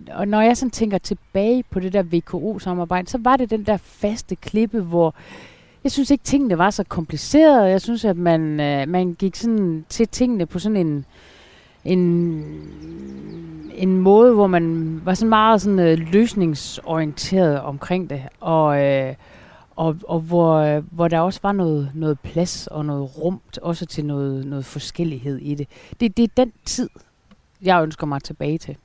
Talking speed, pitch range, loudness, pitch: 180 wpm, 155-205 Hz, -19 LUFS, 175 Hz